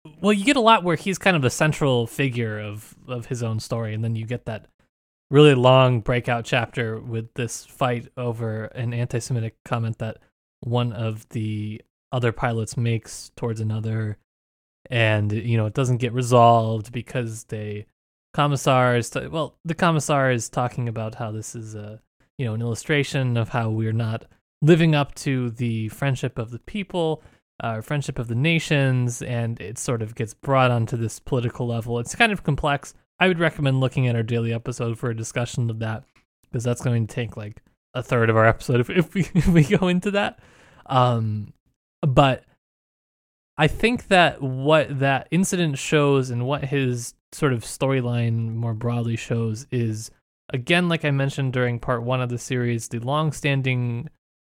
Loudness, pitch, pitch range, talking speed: -23 LUFS, 125 Hz, 115-140 Hz, 180 wpm